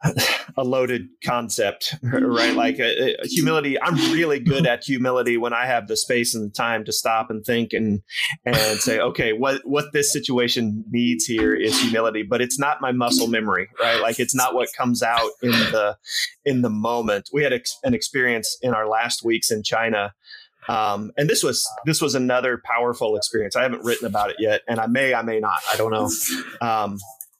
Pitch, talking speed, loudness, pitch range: 120 Hz, 195 wpm, -21 LUFS, 110-125 Hz